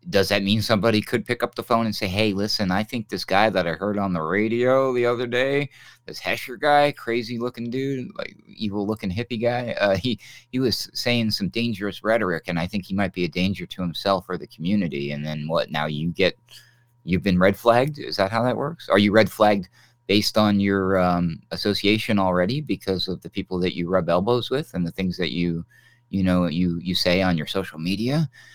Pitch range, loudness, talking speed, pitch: 90-120 Hz, -23 LUFS, 220 wpm, 105 Hz